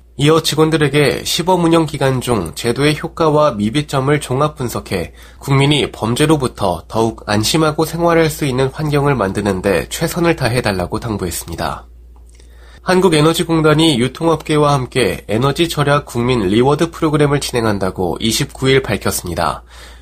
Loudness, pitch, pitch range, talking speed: -15 LUFS, 135 Hz, 100-155 Hz, 335 characters per minute